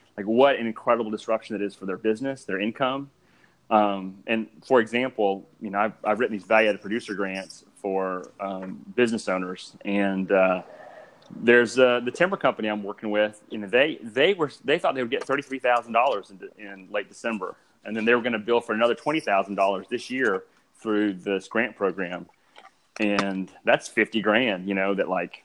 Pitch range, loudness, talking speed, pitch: 100-120 Hz, -25 LUFS, 180 wpm, 105 Hz